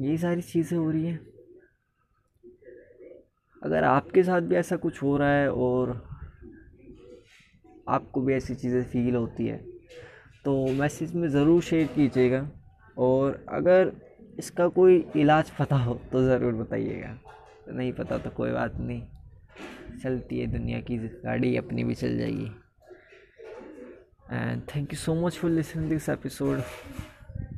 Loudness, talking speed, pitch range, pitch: -26 LUFS, 140 wpm, 120-165 Hz, 140 Hz